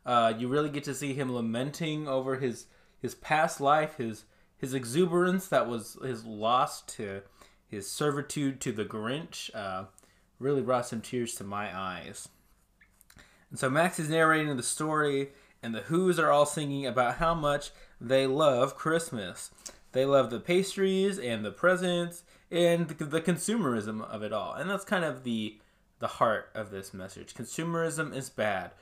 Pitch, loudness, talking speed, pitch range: 140 Hz, -30 LUFS, 165 wpm, 120-160 Hz